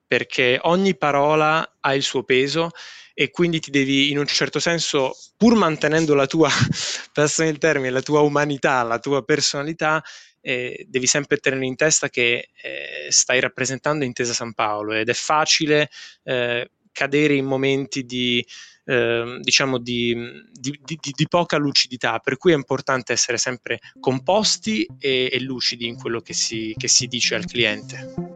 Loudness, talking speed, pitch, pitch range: -20 LUFS, 160 wpm, 140 Hz, 125-155 Hz